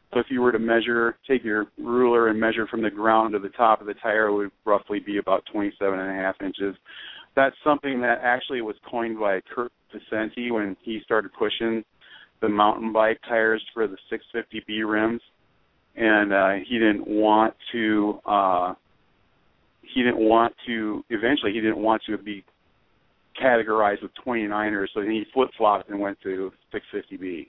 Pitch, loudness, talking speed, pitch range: 110 Hz, -24 LUFS, 170 wpm, 105-115 Hz